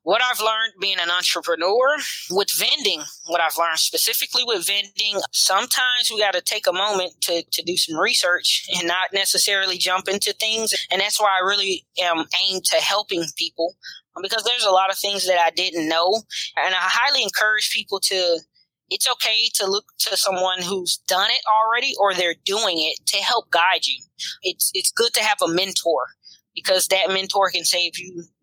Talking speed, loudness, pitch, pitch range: 185 wpm, -19 LUFS, 190 Hz, 175-215 Hz